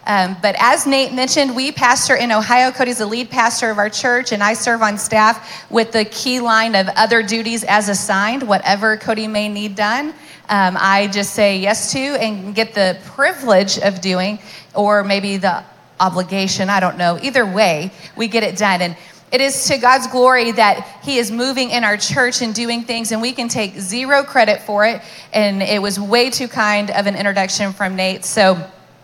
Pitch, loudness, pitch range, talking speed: 215 Hz, -15 LUFS, 200-245 Hz, 200 wpm